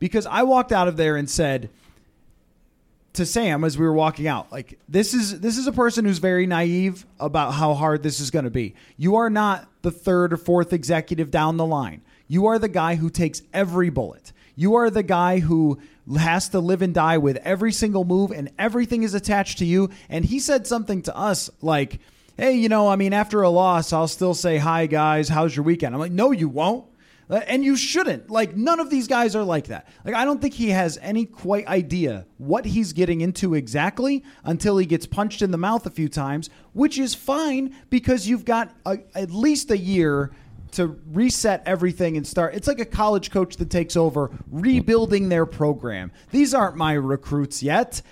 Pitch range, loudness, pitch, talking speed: 155-220 Hz, -21 LUFS, 180 Hz, 210 wpm